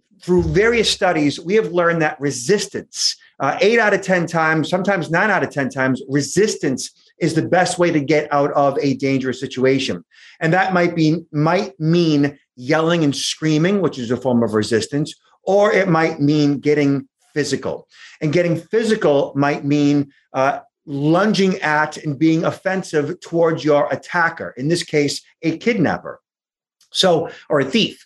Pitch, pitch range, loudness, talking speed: 160 Hz, 145-180 Hz, -18 LUFS, 165 wpm